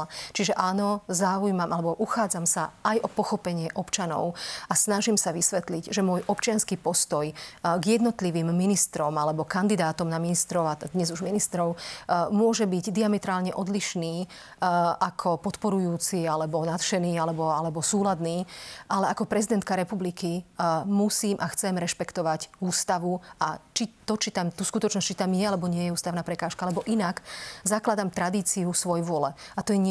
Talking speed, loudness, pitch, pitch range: 150 wpm, -26 LUFS, 180 Hz, 170-205 Hz